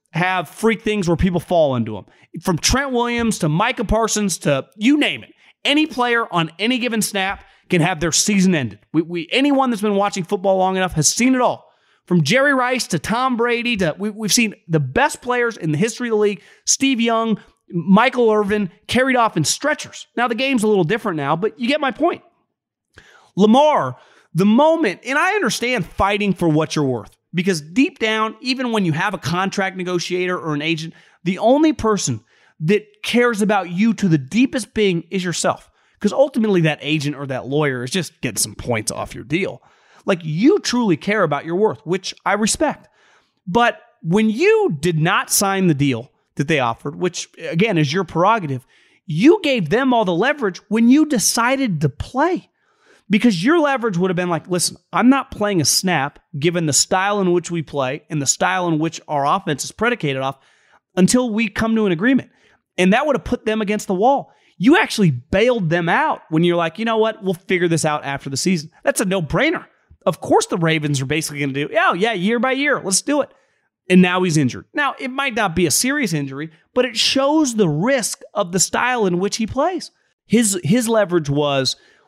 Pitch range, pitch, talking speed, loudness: 170-235 Hz, 195 Hz, 205 wpm, -18 LUFS